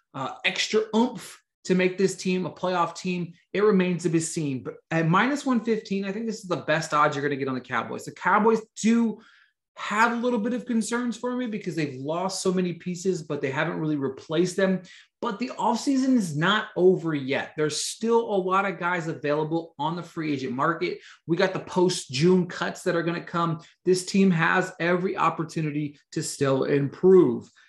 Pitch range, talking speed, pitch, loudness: 160-210 Hz, 205 wpm, 180 Hz, -25 LUFS